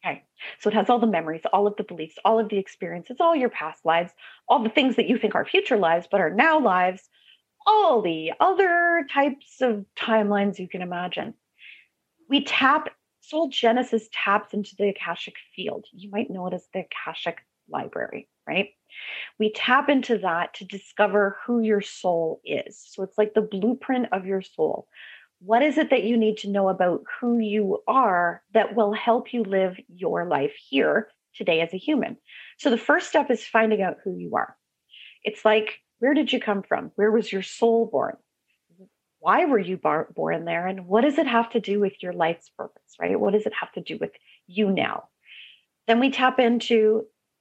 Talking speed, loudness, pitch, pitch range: 195 wpm, -23 LUFS, 215 Hz, 190-245 Hz